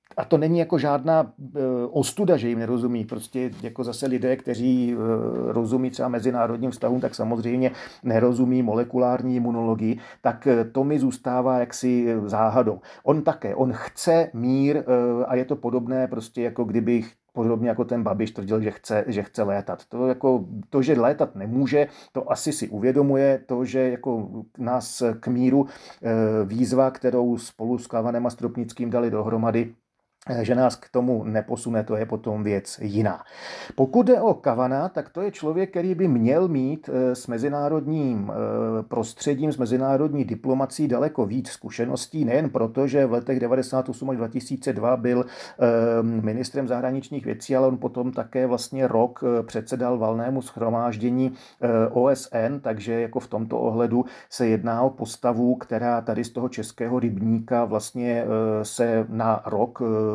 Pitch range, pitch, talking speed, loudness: 115-130 Hz, 125 Hz, 150 wpm, -24 LUFS